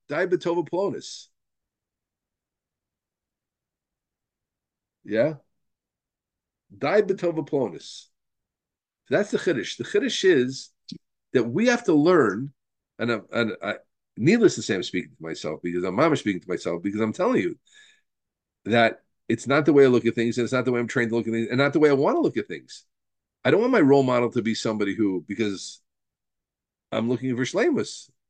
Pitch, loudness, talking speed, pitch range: 125 Hz, -23 LUFS, 175 wpm, 110-160 Hz